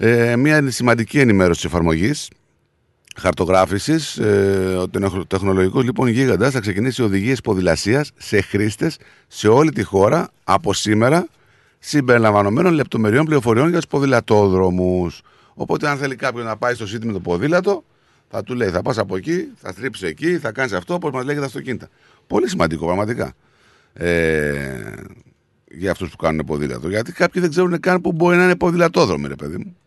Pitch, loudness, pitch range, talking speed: 115 Hz, -18 LUFS, 95-150 Hz, 160 wpm